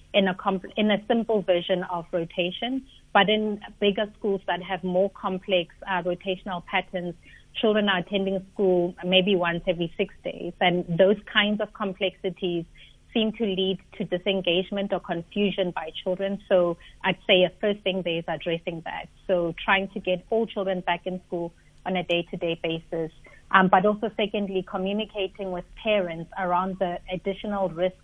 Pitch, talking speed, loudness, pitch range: 190 Hz, 165 wpm, -26 LUFS, 180-200 Hz